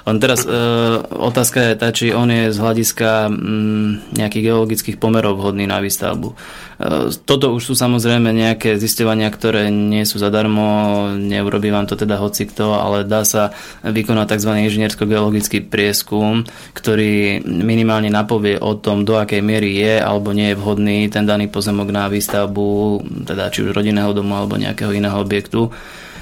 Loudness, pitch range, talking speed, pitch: -16 LUFS, 105-110 Hz, 160 wpm, 105 Hz